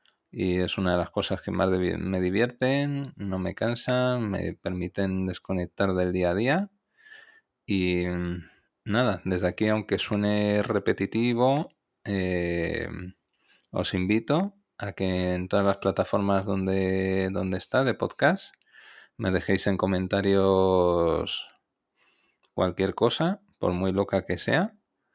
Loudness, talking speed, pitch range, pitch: -26 LUFS, 125 wpm, 95-115 Hz, 95 Hz